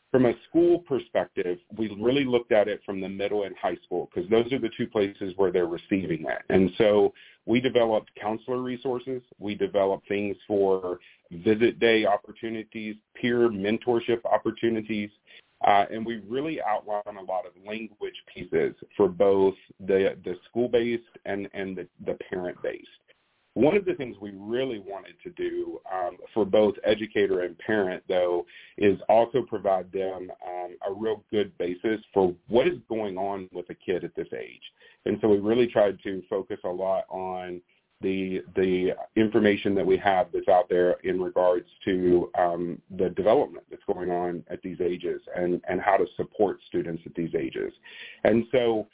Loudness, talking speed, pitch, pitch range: -26 LUFS, 170 wpm, 110 Hz, 95-125 Hz